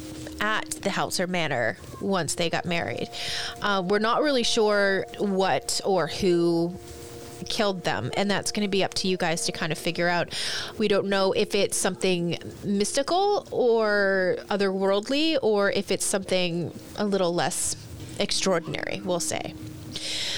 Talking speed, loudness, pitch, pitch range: 155 wpm, -25 LUFS, 195 Hz, 170-205 Hz